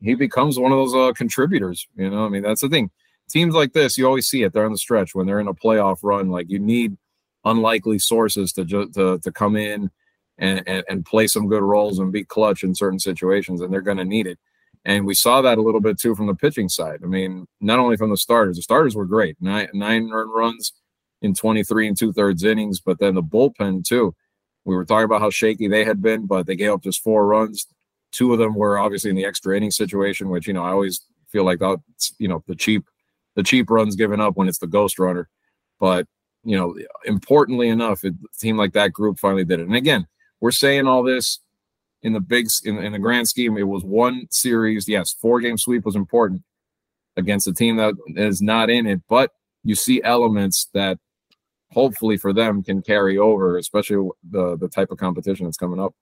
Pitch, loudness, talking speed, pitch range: 105 Hz, -19 LUFS, 225 wpm, 95-110 Hz